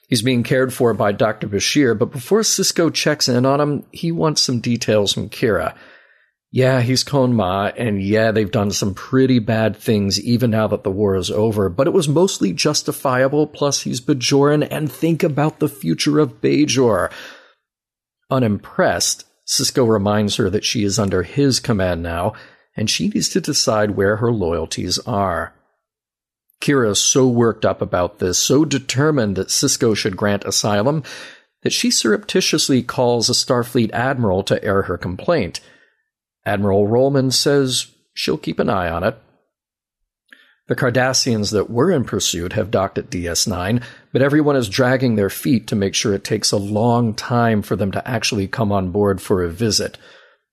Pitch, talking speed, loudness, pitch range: 120 Hz, 170 wpm, -18 LUFS, 105-140 Hz